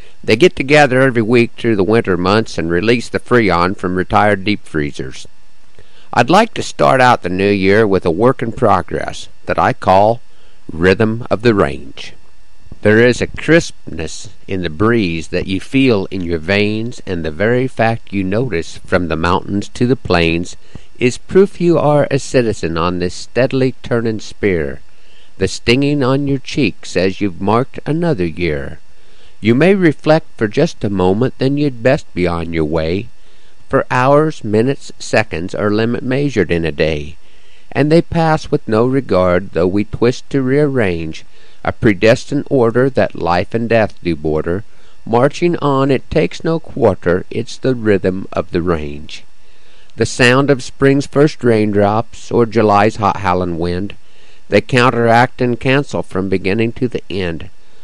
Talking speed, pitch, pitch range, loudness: 165 wpm, 110 Hz, 90-130 Hz, -14 LUFS